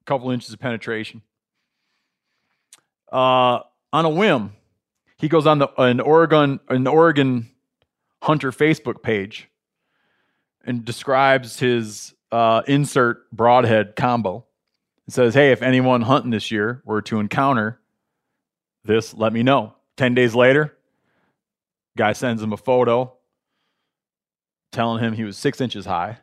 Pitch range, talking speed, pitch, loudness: 110-135 Hz, 130 wpm, 125 Hz, -19 LUFS